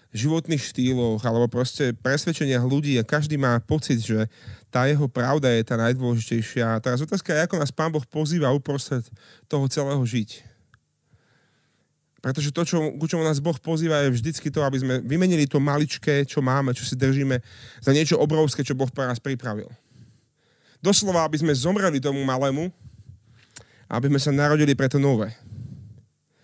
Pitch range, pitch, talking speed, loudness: 120-150 Hz, 135 Hz, 165 wpm, -23 LUFS